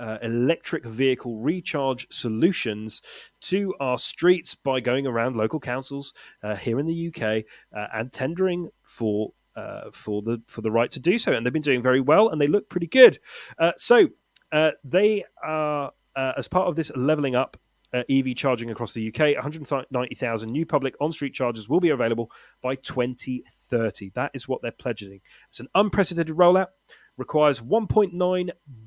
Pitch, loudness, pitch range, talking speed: 135 Hz, -24 LUFS, 120-165 Hz, 170 wpm